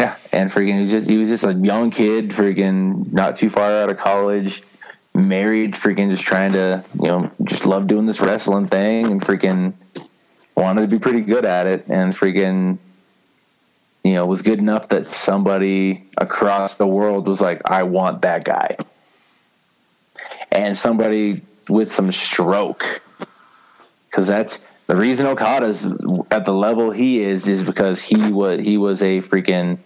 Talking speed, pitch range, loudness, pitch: 160 wpm, 95-105 Hz, -18 LUFS, 100 Hz